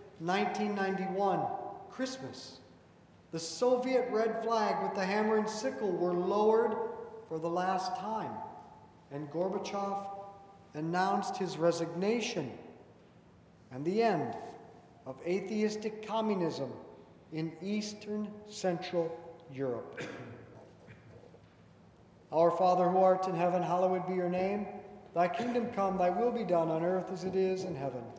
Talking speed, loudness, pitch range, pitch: 120 wpm, -33 LUFS, 175-210 Hz, 190 Hz